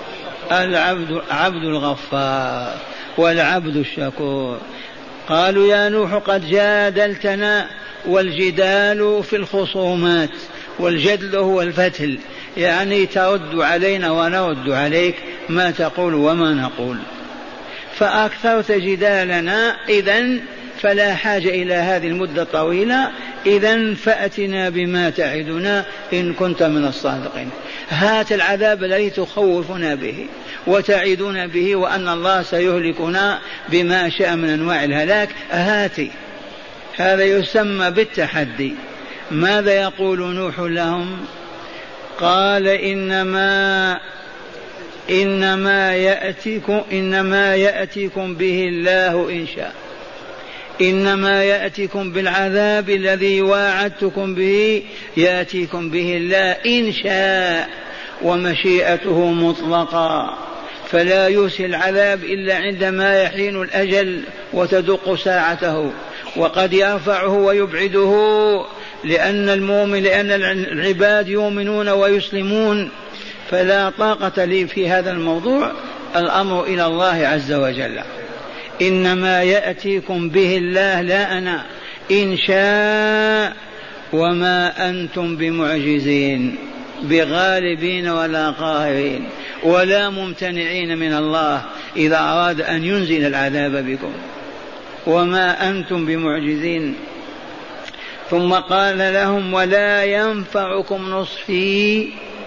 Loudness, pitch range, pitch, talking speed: -17 LUFS, 175-200 Hz, 190 Hz, 90 wpm